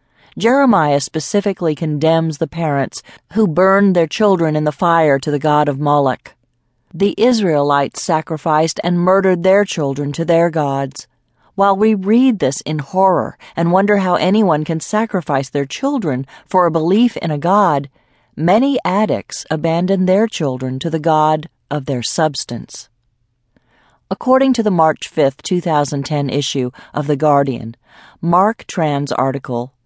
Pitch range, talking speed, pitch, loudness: 145-190 Hz, 145 wpm, 160 Hz, -16 LUFS